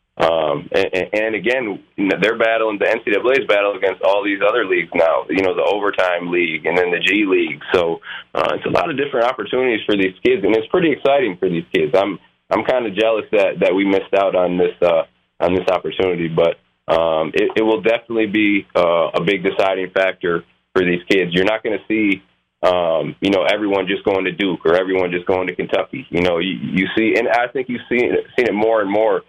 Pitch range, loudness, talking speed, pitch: 90-140 Hz, -17 LUFS, 225 wpm, 100 Hz